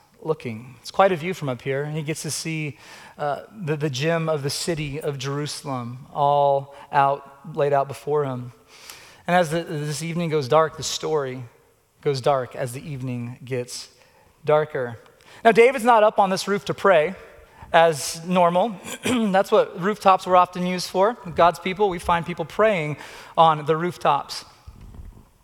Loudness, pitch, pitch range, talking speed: -22 LUFS, 155 Hz, 140-180 Hz, 170 wpm